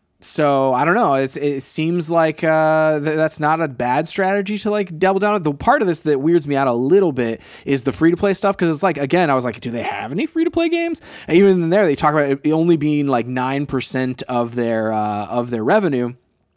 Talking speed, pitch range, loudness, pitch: 250 wpm, 130-175 Hz, -18 LUFS, 150 Hz